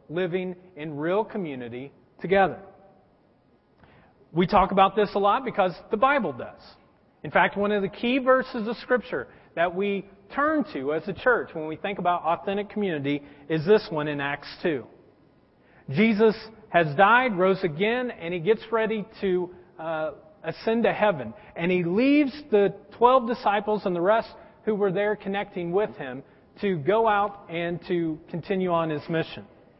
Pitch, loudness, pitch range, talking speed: 195 Hz, -25 LUFS, 170-215 Hz, 165 wpm